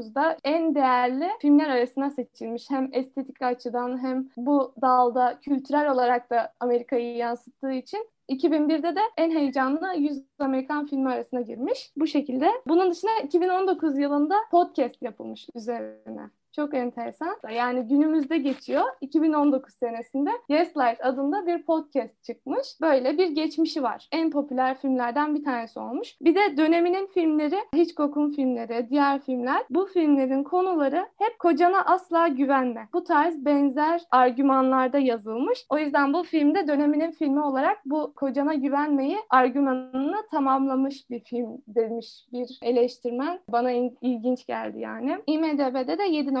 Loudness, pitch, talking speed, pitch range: -25 LUFS, 280 Hz, 135 wpm, 250-315 Hz